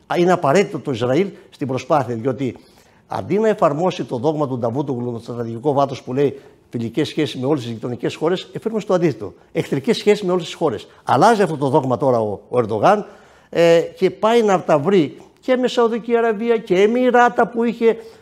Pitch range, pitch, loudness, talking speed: 135-210 Hz, 165 Hz, -18 LUFS, 190 wpm